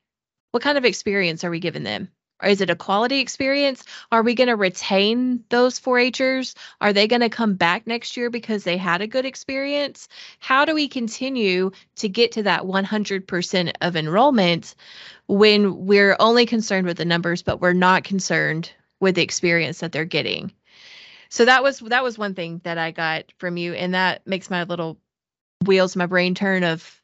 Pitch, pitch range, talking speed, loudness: 200 Hz, 175-240 Hz, 190 wpm, -20 LUFS